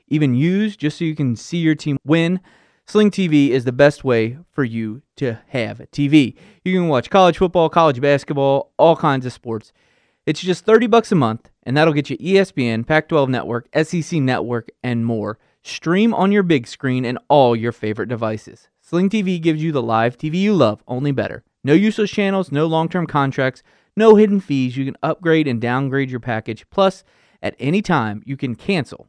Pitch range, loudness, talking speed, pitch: 125-175 Hz, -18 LUFS, 195 wpm, 145 Hz